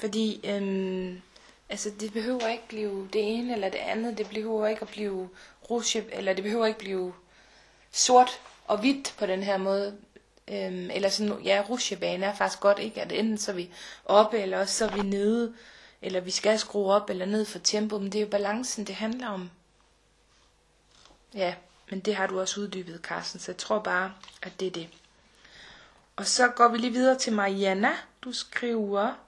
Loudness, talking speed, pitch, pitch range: -28 LUFS, 190 wpm, 205 Hz, 190-220 Hz